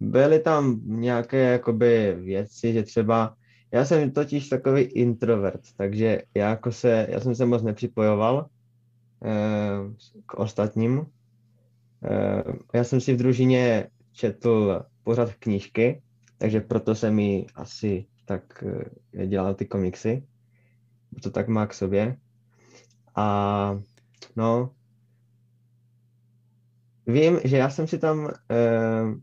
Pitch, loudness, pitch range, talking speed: 120 Hz, -24 LUFS, 110-120 Hz, 115 wpm